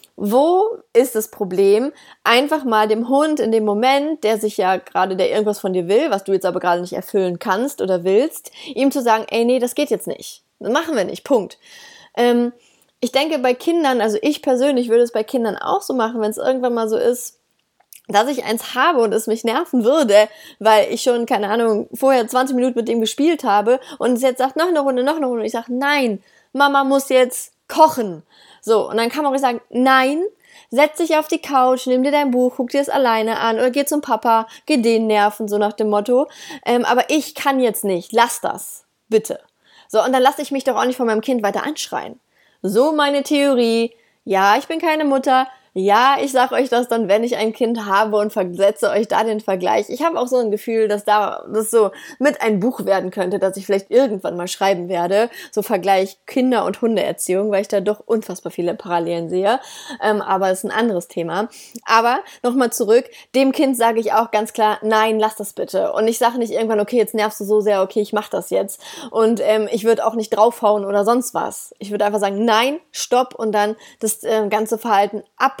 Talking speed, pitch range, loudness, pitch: 220 wpm, 210-265 Hz, -18 LUFS, 230 Hz